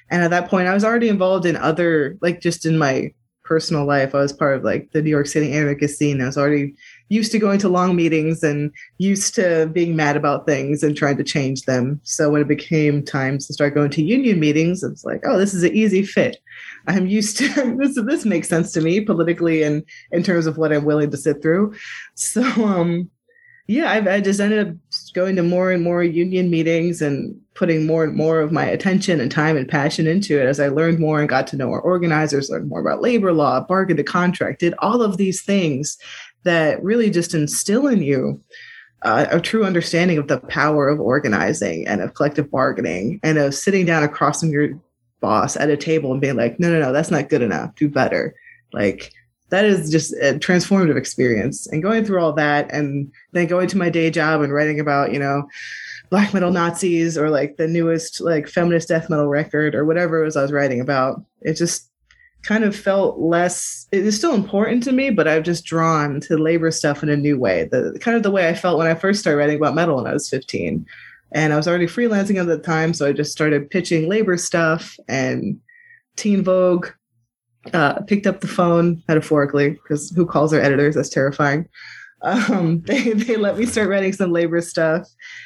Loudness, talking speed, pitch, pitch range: -18 LUFS, 215 wpm, 165 Hz, 150-185 Hz